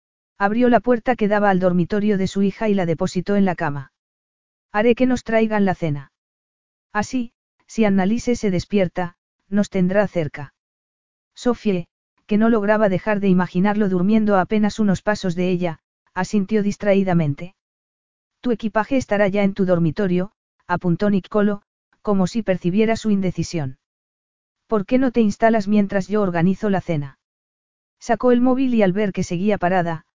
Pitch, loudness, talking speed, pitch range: 200 Hz, -20 LUFS, 155 wpm, 180-215 Hz